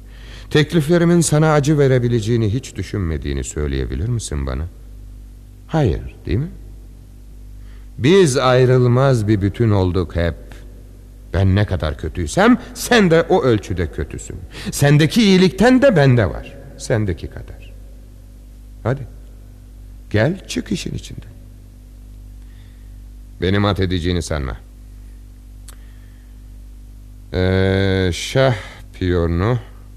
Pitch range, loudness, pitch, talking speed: 90-125 Hz, -17 LUFS, 105 Hz, 90 wpm